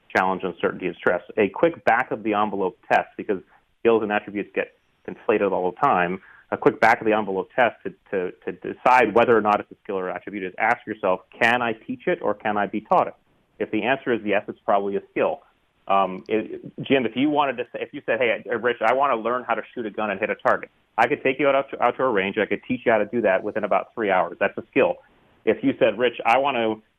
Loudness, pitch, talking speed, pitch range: -23 LUFS, 110 Hz, 265 wpm, 105-130 Hz